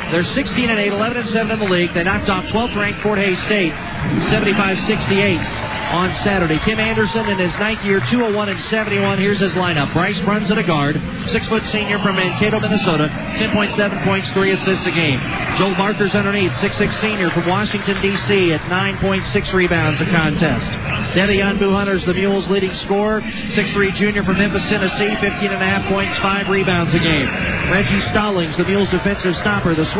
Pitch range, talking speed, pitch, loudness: 180-210 Hz, 160 wpm, 195 Hz, -17 LUFS